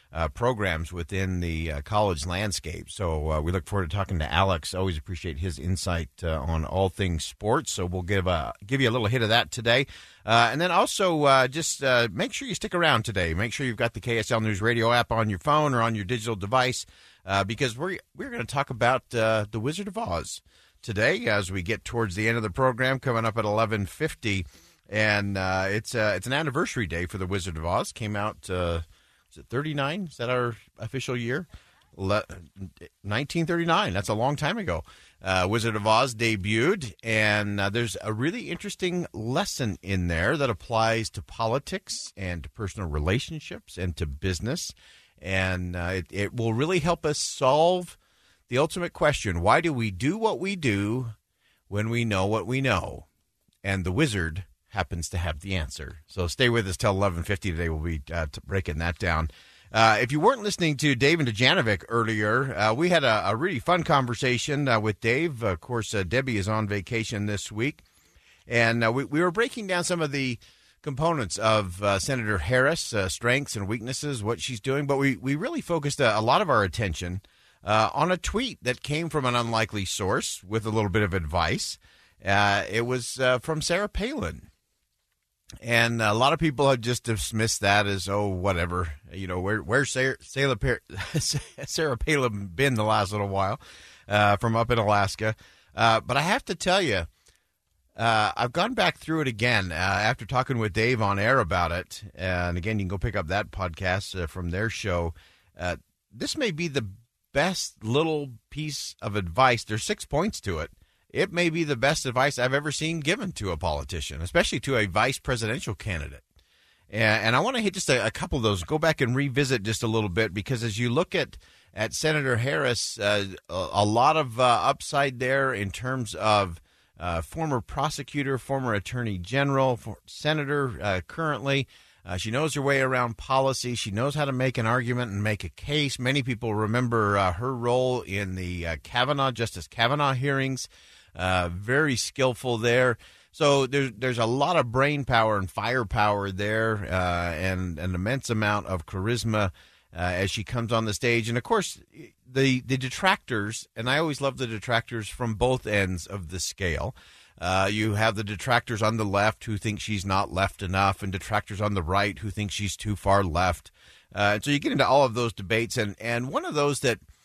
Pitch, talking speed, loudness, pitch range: 110 Hz, 195 wpm, -26 LUFS, 95-130 Hz